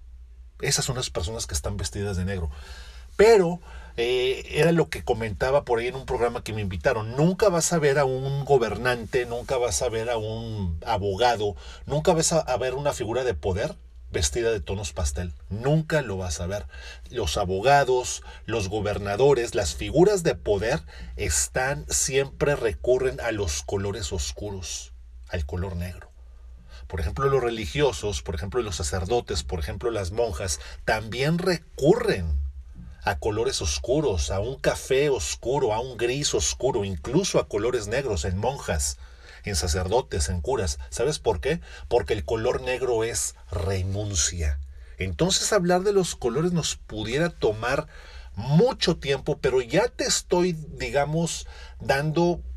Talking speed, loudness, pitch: 150 wpm, -25 LUFS, 105 Hz